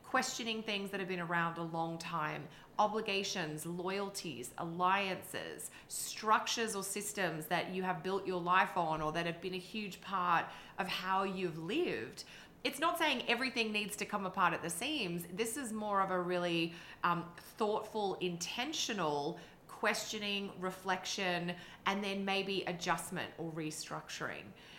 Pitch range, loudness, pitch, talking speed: 175-210 Hz, -37 LUFS, 190 Hz, 150 wpm